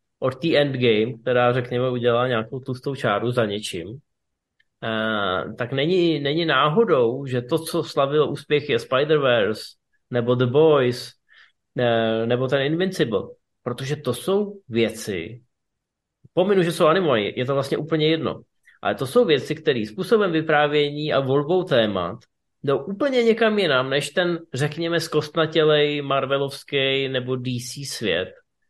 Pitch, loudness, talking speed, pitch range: 140 Hz, -22 LUFS, 135 wpm, 125-160 Hz